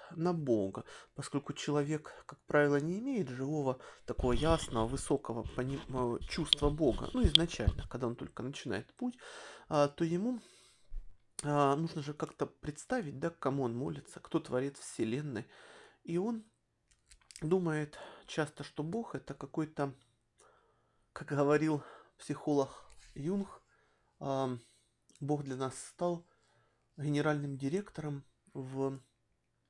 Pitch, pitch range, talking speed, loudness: 145 Hz, 130-155 Hz, 115 wpm, -36 LUFS